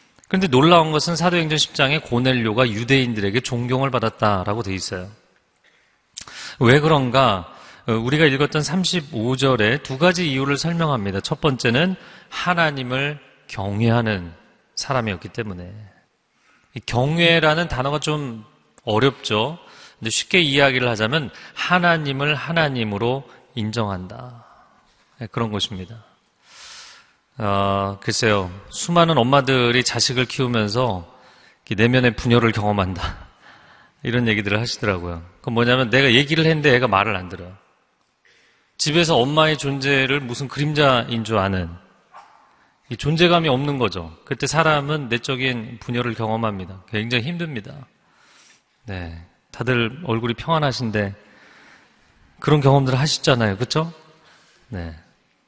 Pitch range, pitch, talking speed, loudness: 110-145 Hz, 125 Hz, 275 characters per minute, -19 LUFS